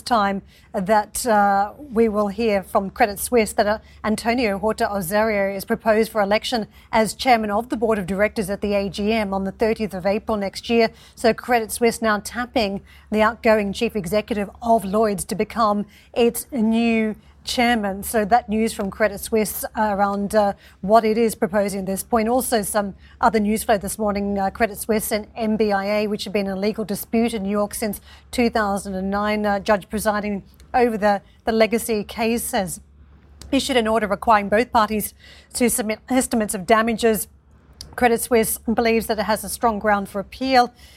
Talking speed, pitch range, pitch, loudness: 175 wpm, 205-230 Hz, 220 Hz, -21 LUFS